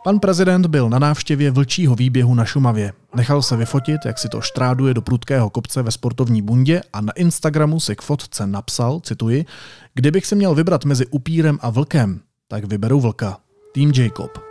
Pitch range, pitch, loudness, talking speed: 120-150 Hz, 135 Hz, -18 LUFS, 180 wpm